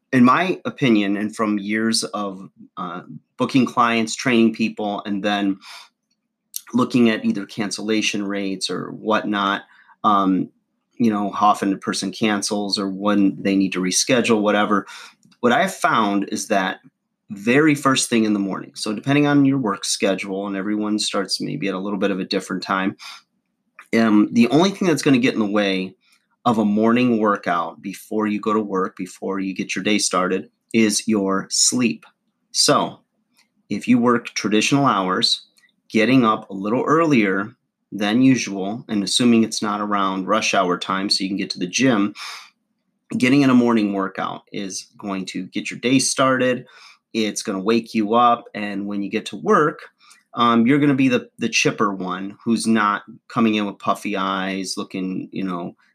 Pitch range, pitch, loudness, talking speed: 100-120 Hz, 105 Hz, -20 LUFS, 180 wpm